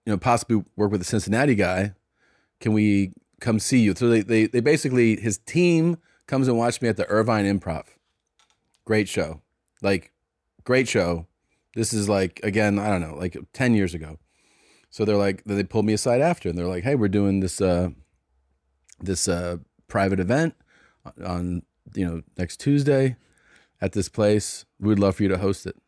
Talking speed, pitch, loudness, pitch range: 185 wpm, 105 Hz, -23 LUFS, 90-115 Hz